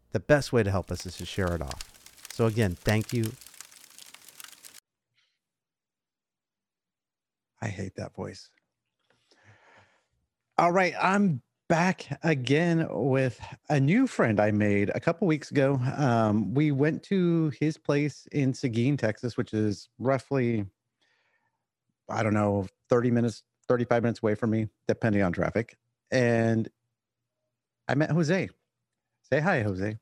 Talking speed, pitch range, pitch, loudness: 130 wpm, 105-145 Hz, 120 Hz, -27 LUFS